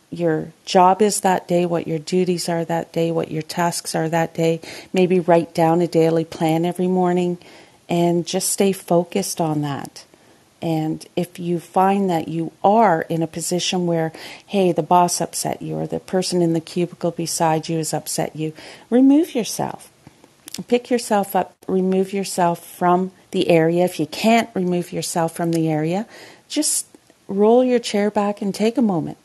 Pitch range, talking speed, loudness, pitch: 165-190 Hz, 175 wpm, -20 LUFS, 175 Hz